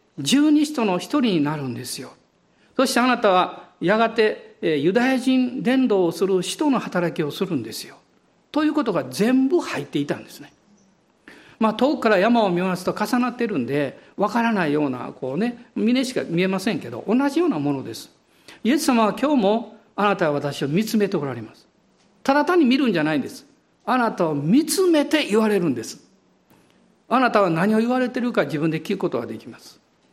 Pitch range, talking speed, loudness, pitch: 180-255 Hz, 375 characters per minute, -21 LUFS, 220 Hz